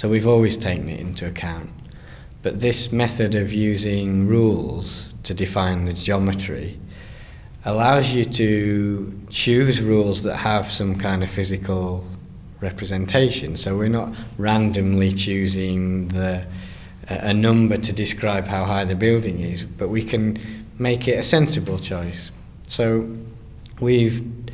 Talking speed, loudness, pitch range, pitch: 130 wpm, -21 LUFS, 95-115 Hz, 105 Hz